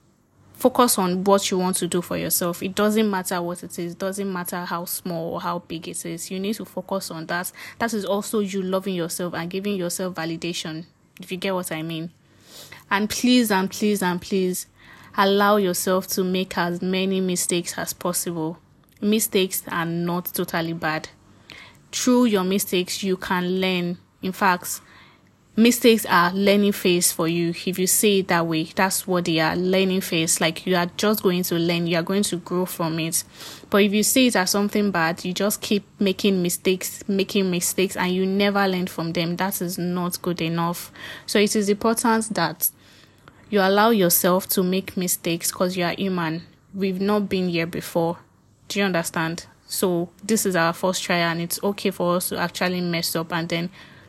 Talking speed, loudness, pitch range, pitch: 190 wpm, -22 LUFS, 170-195 Hz, 185 Hz